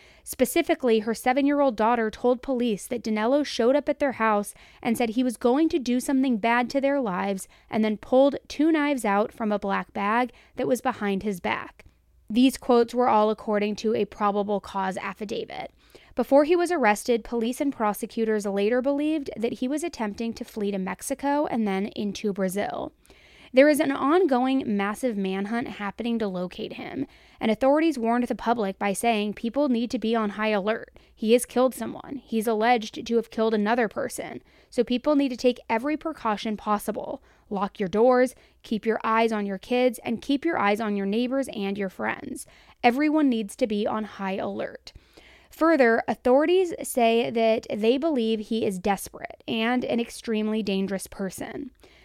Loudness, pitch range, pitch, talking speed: -25 LUFS, 210-260 Hz, 235 Hz, 180 wpm